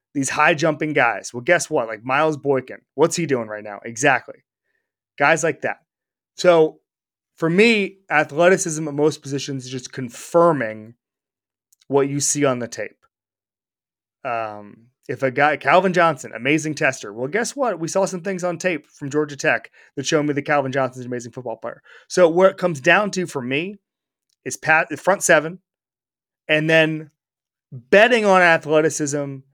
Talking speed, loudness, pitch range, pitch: 170 wpm, -19 LUFS, 130-170 Hz, 150 Hz